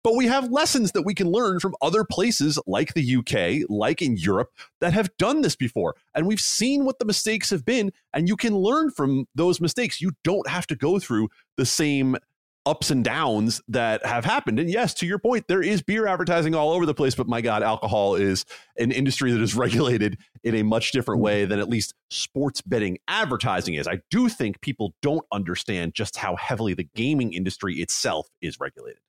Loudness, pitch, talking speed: -24 LUFS, 145 Hz, 210 wpm